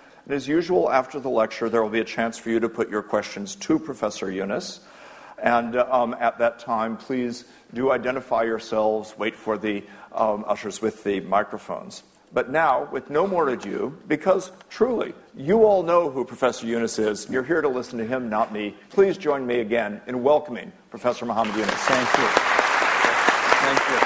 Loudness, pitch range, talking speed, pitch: -23 LUFS, 110-140 Hz, 180 wpm, 120 Hz